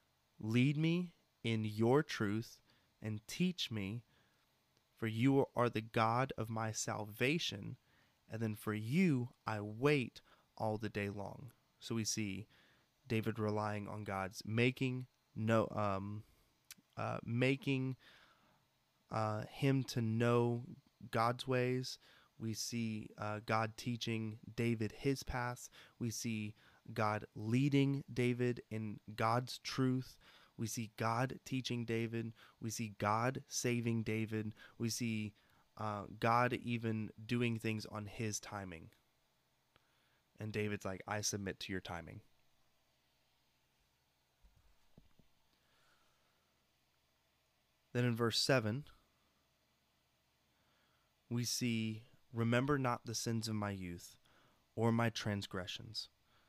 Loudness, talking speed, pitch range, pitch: -39 LUFS, 110 wpm, 105-120 Hz, 110 Hz